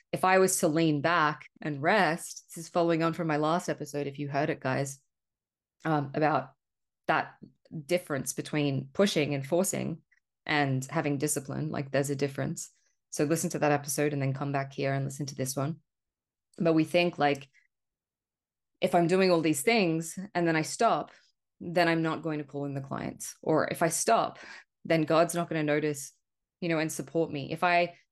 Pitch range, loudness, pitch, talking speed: 145-170 Hz, -29 LUFS, 155 Hz, 195 wpm